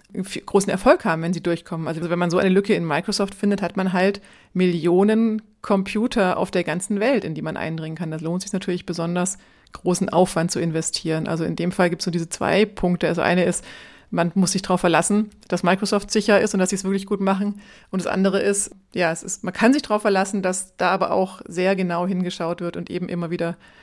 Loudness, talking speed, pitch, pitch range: -22 LUFS, 230 wpm, 185 Hz, 175-200 Hz